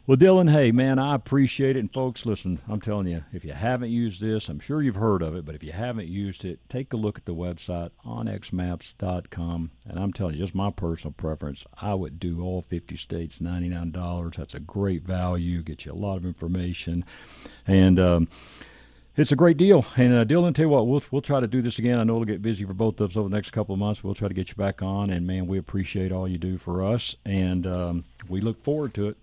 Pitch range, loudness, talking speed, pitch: 90-115 Hz, -25 LUFS, 245 wpm, 95 Hz